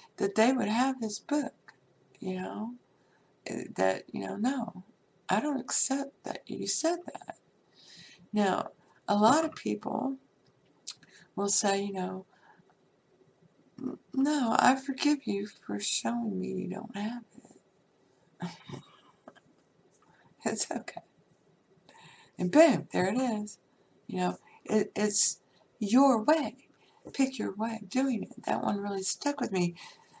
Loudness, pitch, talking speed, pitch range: -30 LUFS, 220 Hz, 125 wpm, 200-270 Hz